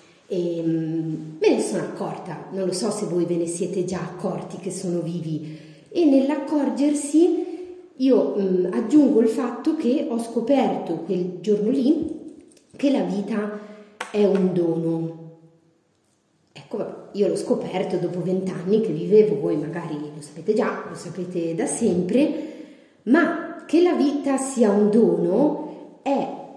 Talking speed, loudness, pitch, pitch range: 140 wpm, -22 LUFS, 210 Hz, 175-275 Hz